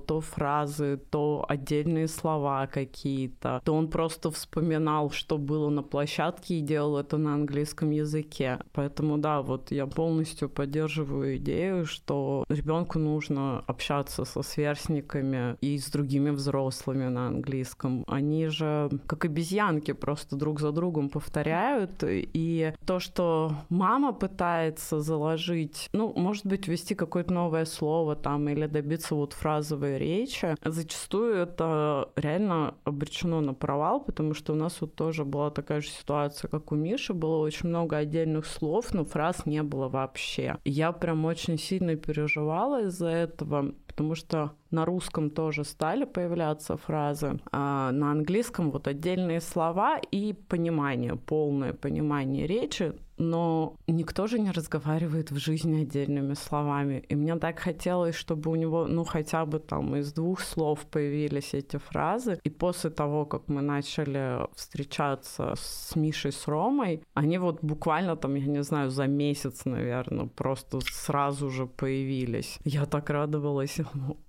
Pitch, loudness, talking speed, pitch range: 155 Hz, -30 LUFS, 145 wpm, 145-165 Hz